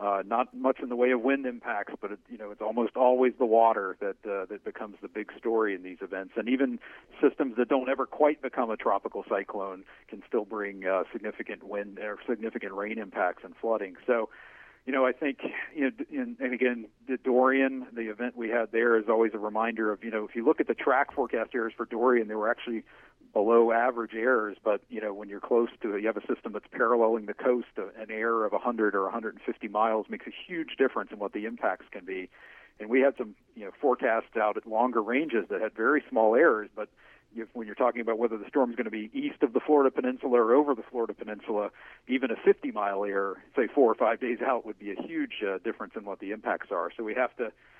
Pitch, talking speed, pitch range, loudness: 115 Hz, 235 wpm, 110-130 Hz, -29 LUFS